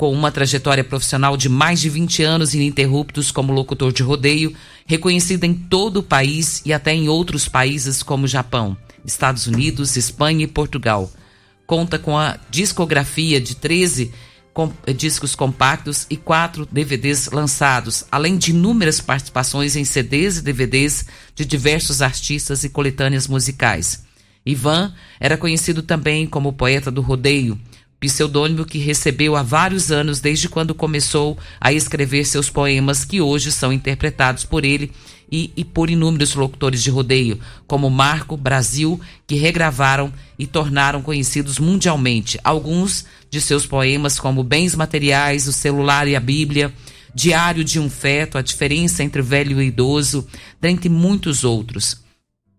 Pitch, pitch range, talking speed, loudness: 145 Hz, 135-155 Hz, 145 wpm, -17 LUFS